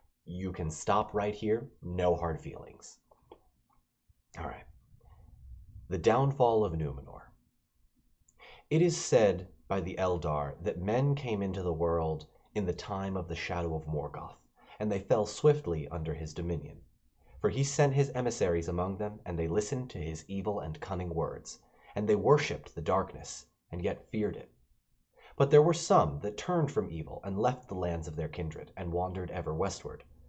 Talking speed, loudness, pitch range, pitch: 170 wpm, -32 LUFS, 85-110 Hz, 95 Hz